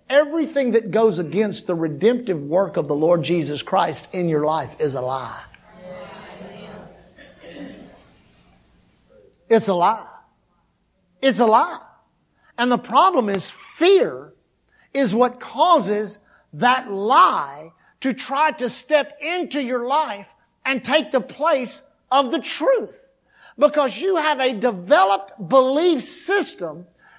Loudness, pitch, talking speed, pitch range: -20 LUFS, 250 Hz, 120 wpm, 190-295 Hz